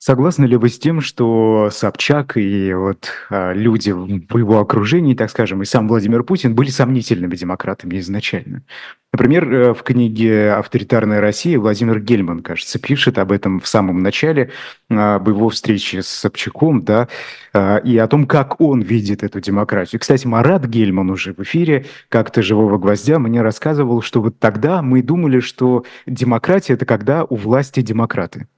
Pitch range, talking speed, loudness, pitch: 105-130 Hz, 155 wpm, -15 LUFS, 115 Hz